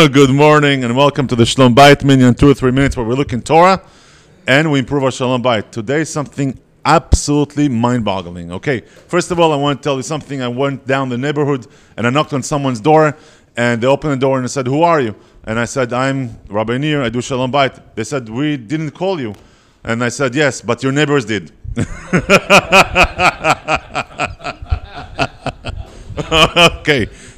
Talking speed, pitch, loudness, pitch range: 190 wpm, 135 Hz, -14 LUFS, 120-150 Hz